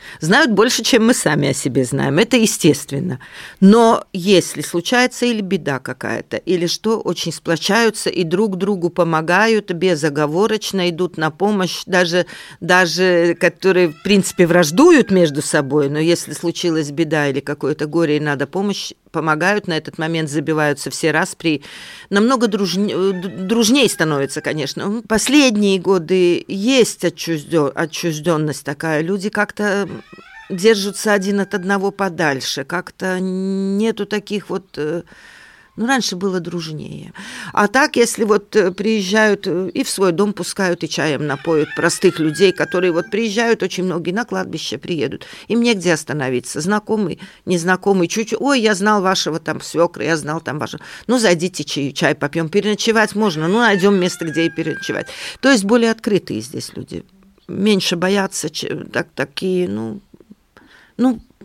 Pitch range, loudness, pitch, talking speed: 160-210 Hz, -17 LUFS, 185 Hz, 140 wpm